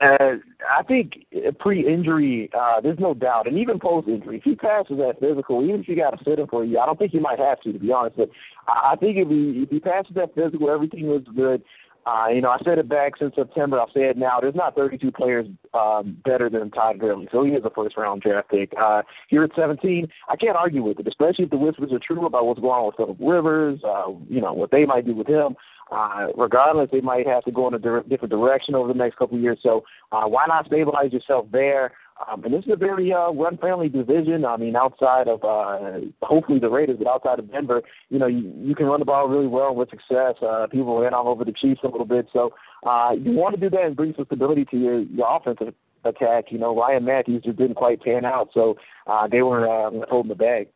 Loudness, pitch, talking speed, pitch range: -21 LUFS, 130 Hz, 250 wpm, 120-155 Hz